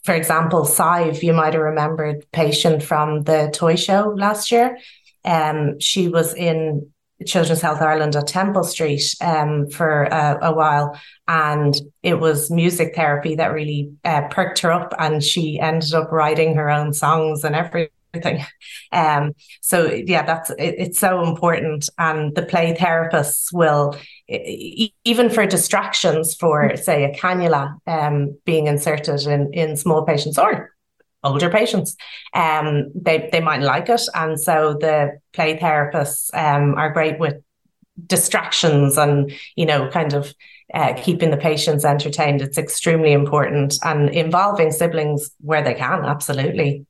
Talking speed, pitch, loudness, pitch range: 150 wpm, 155 Hz, -18 LUFS, 150-170 Hz